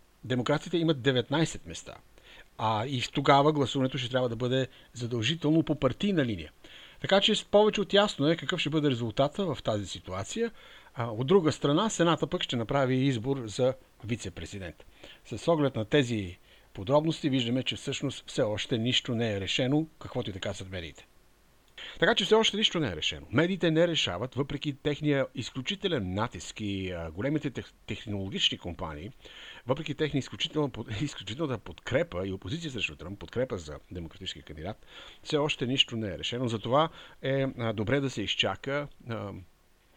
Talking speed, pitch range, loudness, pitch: 150 wpm, 105-150 Hz, -29 LUFS, 130 Hz